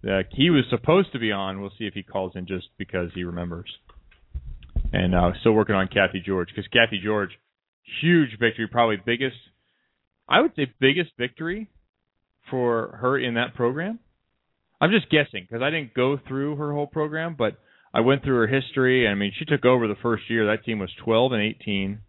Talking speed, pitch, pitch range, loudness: 200 wpm, 115 Hz, 100-135 Hz, -23 LUFS